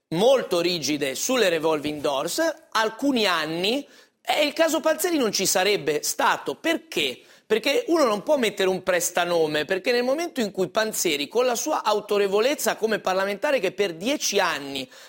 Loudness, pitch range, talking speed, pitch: -23 LUFS, 185-300 Hz, 155 wpm, 220 Hz